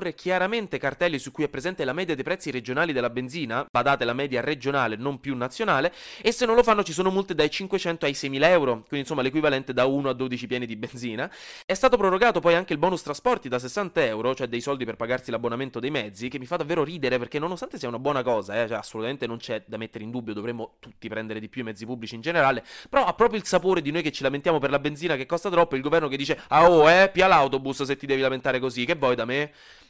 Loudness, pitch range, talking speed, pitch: -24 LUFS, 125-170 Hz, 255 wpm, 140 Hz